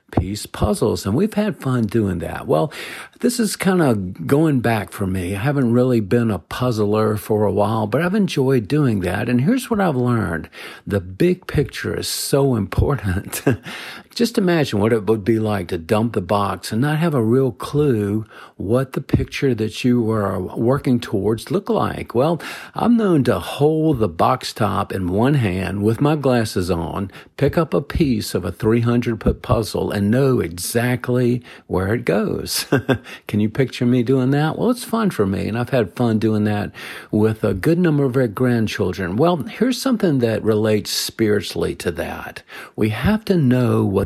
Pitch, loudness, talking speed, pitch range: 120 Hz, -19 LUFS, 185 wpm, 105-145 Hz